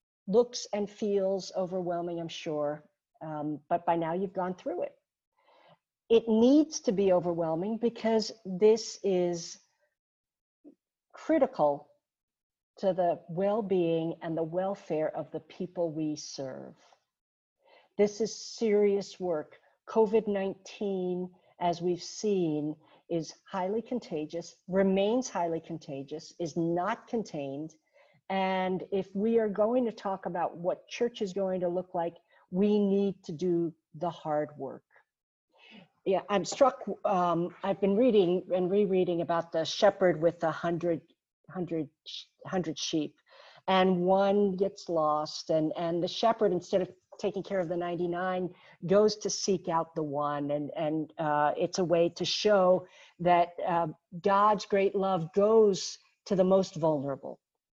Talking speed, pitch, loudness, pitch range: 135 wpm, 185 Hz, -30 LUFS, 165-200 Hz